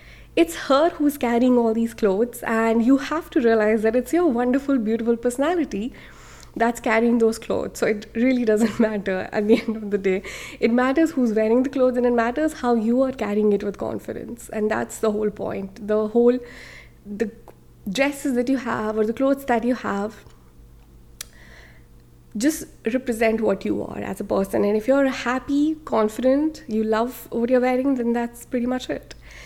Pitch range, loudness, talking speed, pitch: 215-260 Hz, -22 LUFS, 185 wpm, 235 Hz